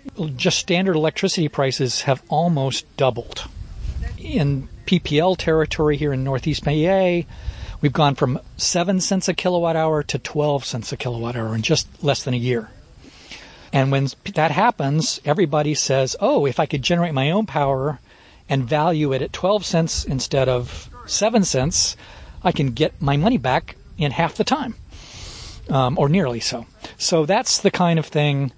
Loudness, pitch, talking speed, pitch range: -20 LUFS, 150 Hz, 165 wpm, 130-170 Hz